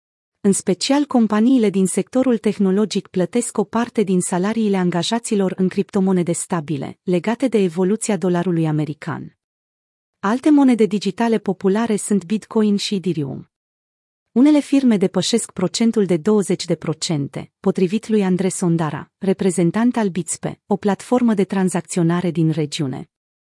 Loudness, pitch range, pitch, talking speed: -19 LUFS, 175-220 Hz, 195 Hz, 120 wpm